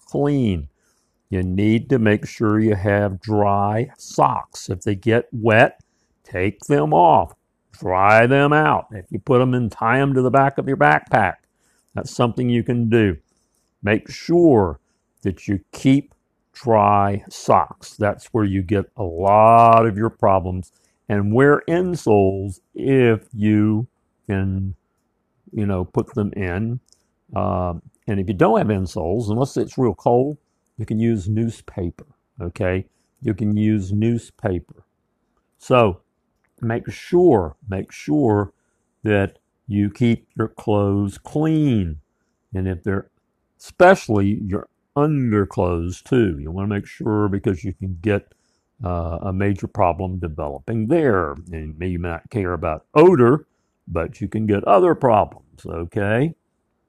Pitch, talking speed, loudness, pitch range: 105 Hz, 140 wpm, -19 LUFS, 95-120 Hz